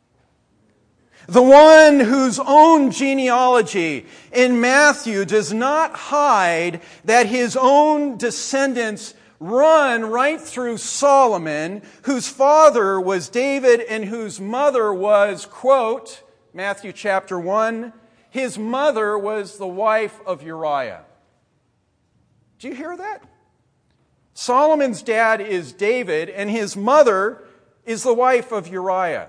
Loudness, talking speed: -16 LUFS, 110 wpm